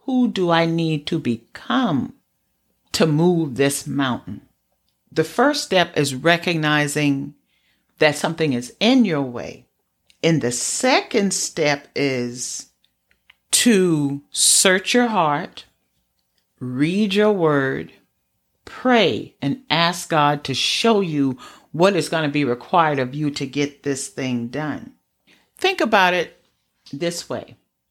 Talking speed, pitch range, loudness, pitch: 125 wpm, 140-180 Hz, -19 LUFS, 150 Hz